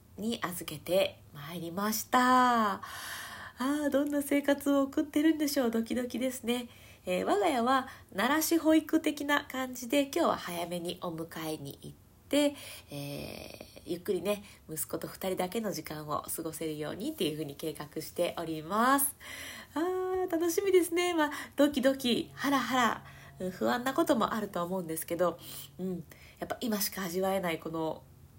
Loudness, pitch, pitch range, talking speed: -31 LUFS, 225 Hz, 170-285 Hz, 320 characters per minute